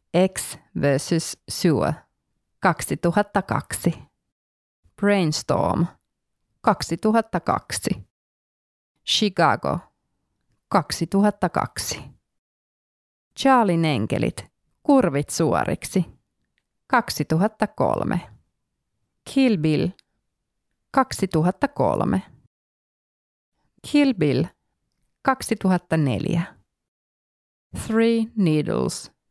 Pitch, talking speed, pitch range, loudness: 180 Hz, 45 wpm, 160-215 Hz, -22 LUFS